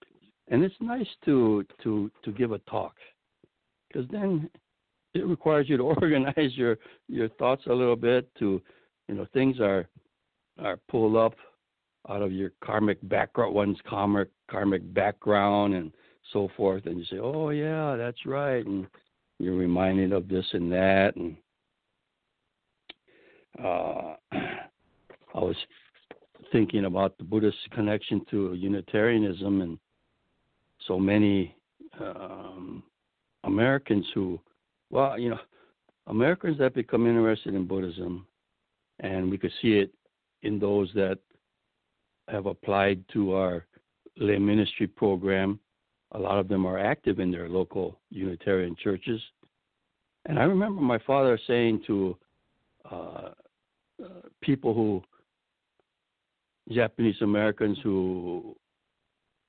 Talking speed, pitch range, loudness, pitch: 120 wpm, 95-120 Hz, -27 LUFS, 105 Hz